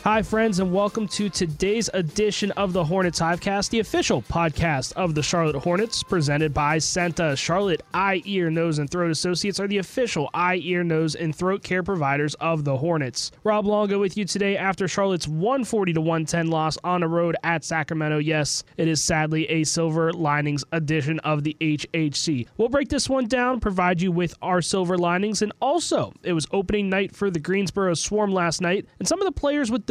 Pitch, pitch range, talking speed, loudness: 180 Hz, 160-200 Hz, 195 wpm, -23 LUFS